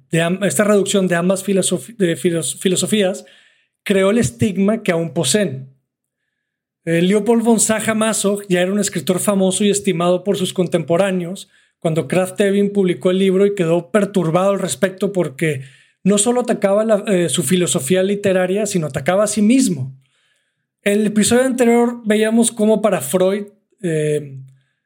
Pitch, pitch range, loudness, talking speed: 190 Hz, 175-205 Hz, -17 LUFS, 155 wpm